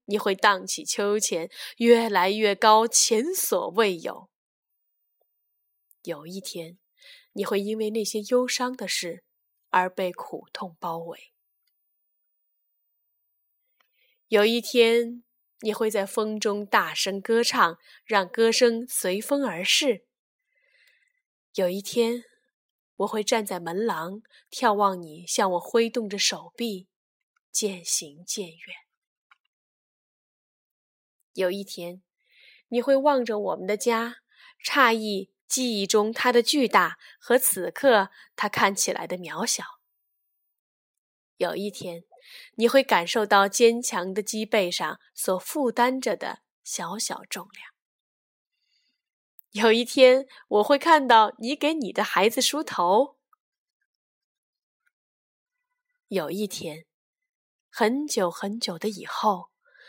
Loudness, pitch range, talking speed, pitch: -24 LUFS, 195-255 Hz, 155 characters per minute, 220 Hz